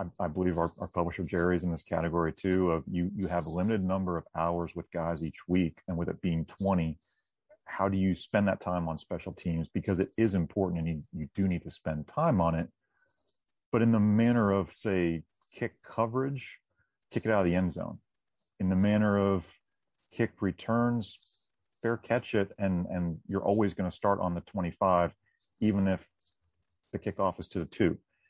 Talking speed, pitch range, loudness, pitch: 195 wpm, 85-100 Hz, -31 LUFS, 90 Hz